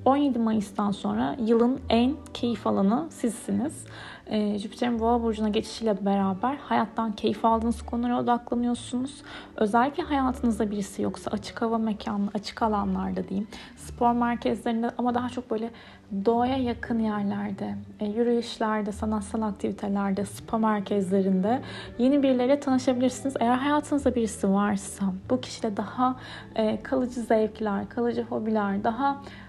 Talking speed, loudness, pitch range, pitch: 120 wpm, -27 LUFS, 210-245 Hz, 230 Hz